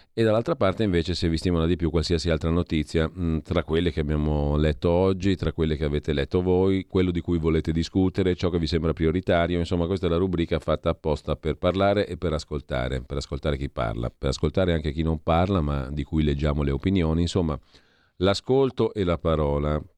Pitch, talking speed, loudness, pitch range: 80 Hz, 200 wpm, -25 LUFS, 75-90 Hz